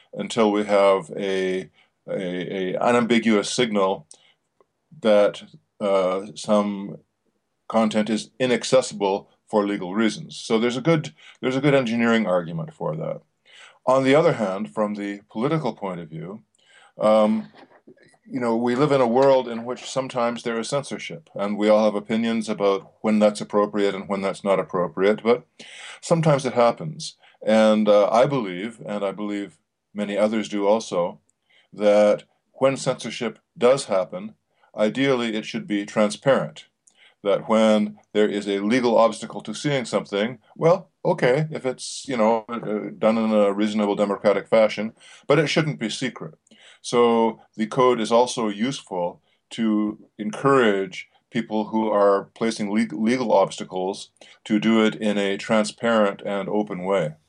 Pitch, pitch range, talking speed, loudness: 110 Hz, 100-120 Hz, 150 wpm, -22 LUFS